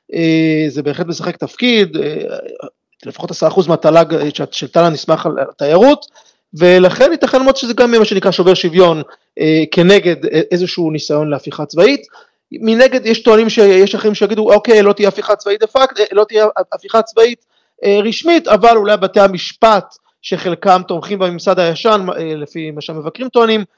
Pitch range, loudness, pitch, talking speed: 165-225 Hz, -12 LUFS, 195 Hz, 160 wpm